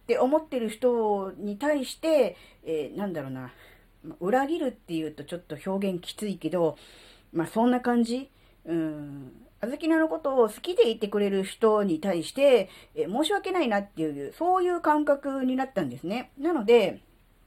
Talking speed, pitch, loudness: 320 characters per minute, 215 Hz, -27 LUFS